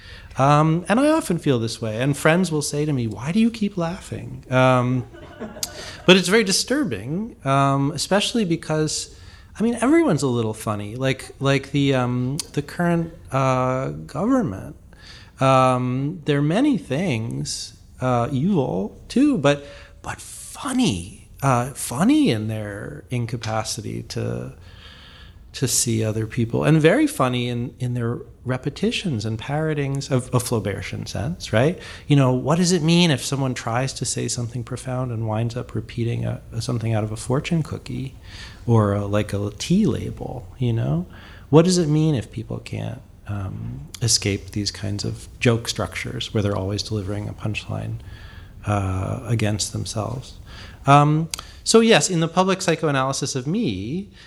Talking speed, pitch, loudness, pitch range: 155 wpm, 125 Hz, -22 LUFS, 110-150 Hz